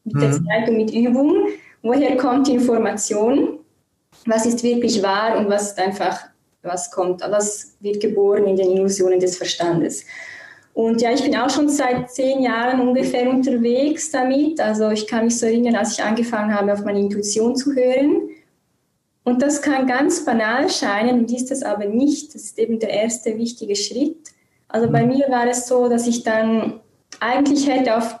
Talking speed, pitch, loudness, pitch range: 175 wpm, 235 Hz, -19 LUFS, 210-260 Hz